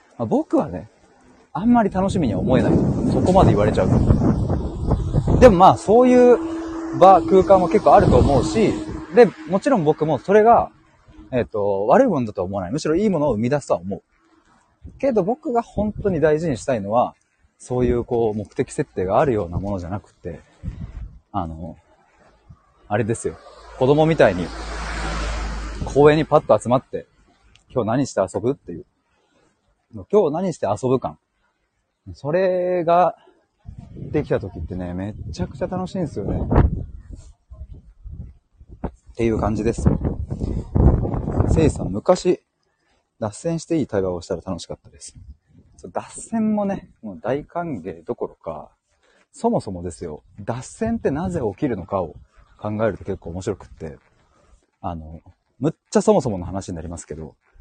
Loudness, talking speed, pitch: -20 LUFS, 295 characters per minute, 130 Hz